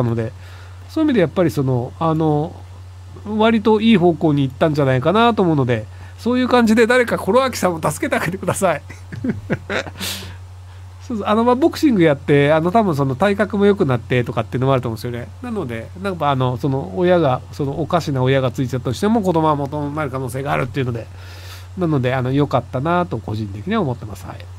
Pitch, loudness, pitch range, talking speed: 135 Hz, -18 LUFS, 110-175 Hz, 450 characters per minute